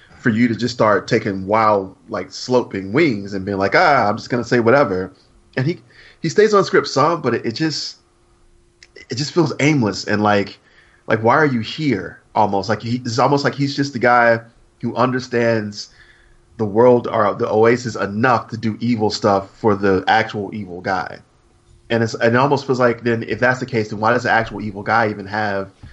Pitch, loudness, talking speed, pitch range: 115 Hz, -18 LUFS, 205 wpm, 105-125 Hz